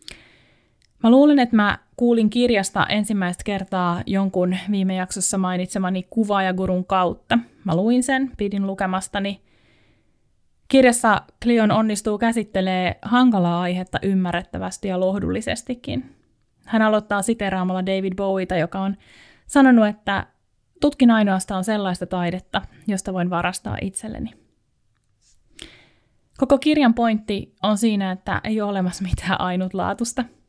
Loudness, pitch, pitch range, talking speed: -21 LUFS, 200 Hz, 185-225 Hz, 110 wpm